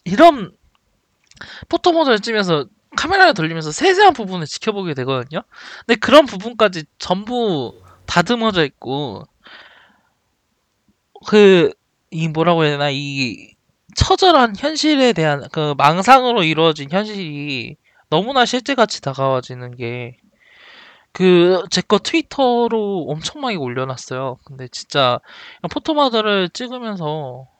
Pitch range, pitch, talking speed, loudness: 145-245 Hz, 180 Hz, 265 characters per minute, -16 LUFS